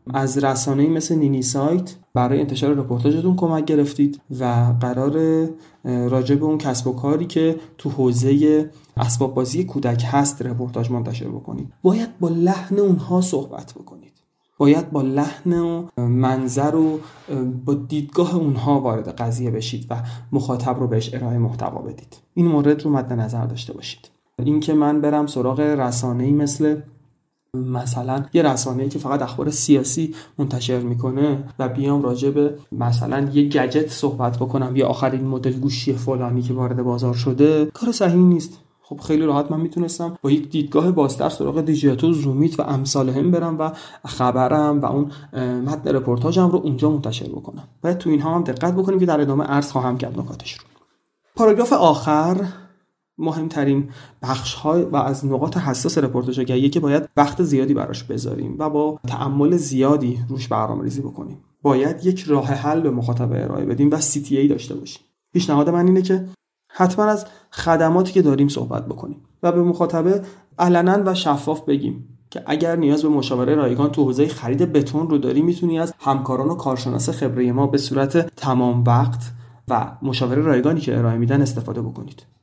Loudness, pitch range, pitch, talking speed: -20 LUFS, 130-160 Hz, 145 Hz, 165 wpm